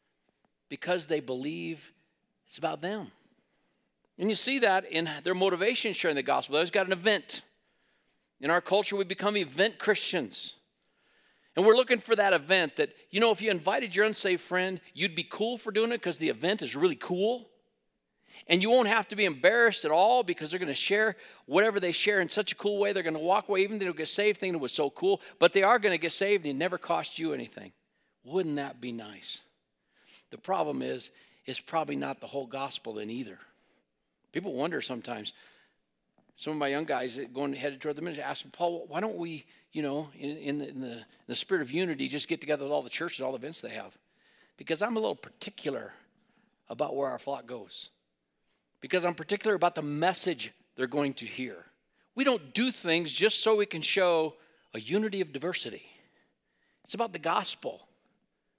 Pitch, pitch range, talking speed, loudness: 175 Hz, 150-205 Hz, 205 wpm, -29 LUFS